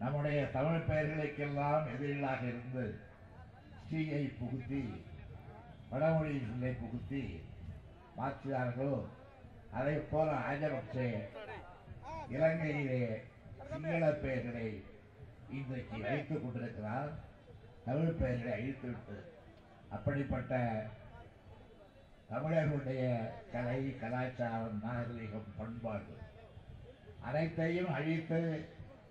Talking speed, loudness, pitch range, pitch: 60 wpm, -38 LUFS, 110-140 Hz, 125 Hz